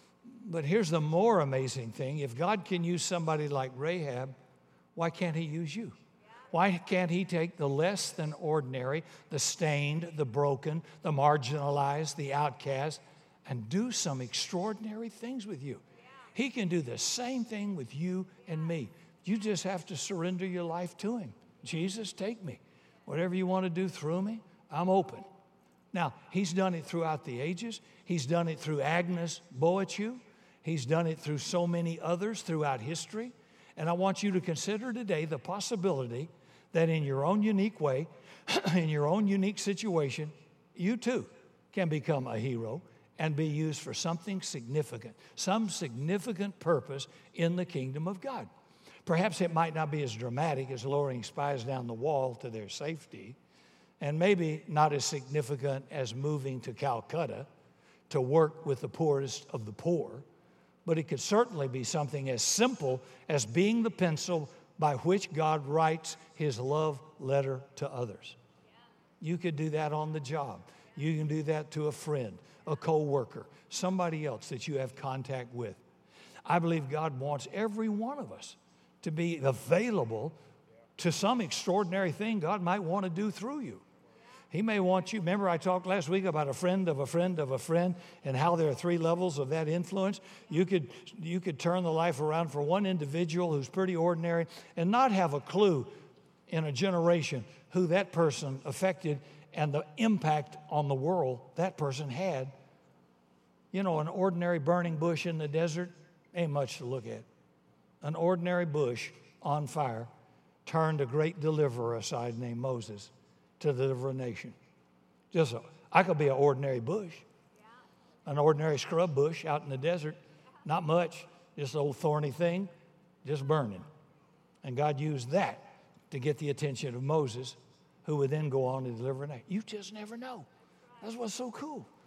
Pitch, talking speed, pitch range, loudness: 160 Hz, 170 wpm, 140-180 Hz, -33 LUFS